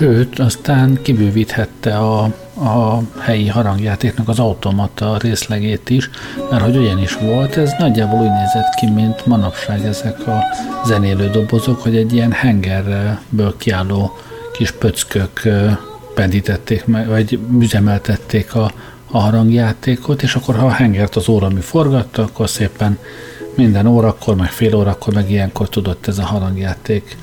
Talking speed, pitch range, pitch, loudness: 135 wpm, 105-120 Hz, 110 Hz, -15 LUFS